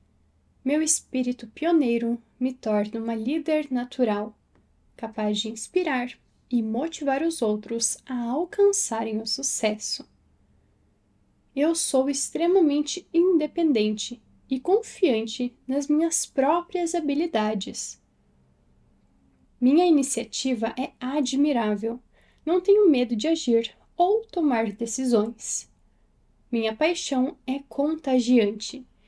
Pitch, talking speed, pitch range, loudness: 260 Hz, 95 wpm, 230-315 Hz, -25 LUFS